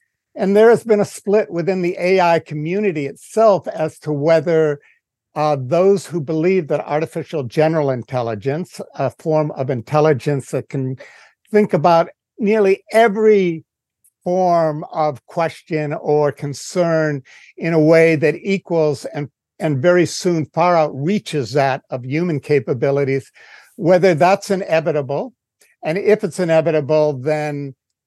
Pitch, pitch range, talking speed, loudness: 160 Hz, 145-185 Hz, 130 wpm, -17 LUFS